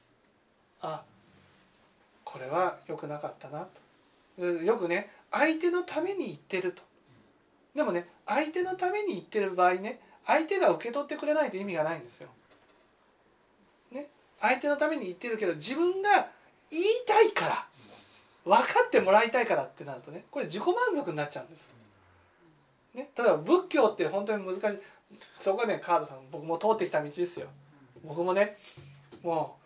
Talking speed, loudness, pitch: 320 characters per minute, -29 LUFS, 215 Hz